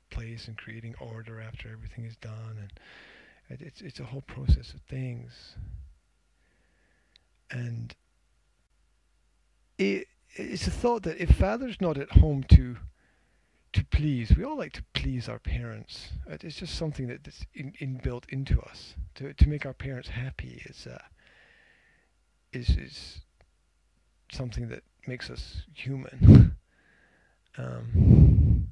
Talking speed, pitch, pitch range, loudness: 135 wpm, 110 Hz, 80-130 Hz, -26 LUFS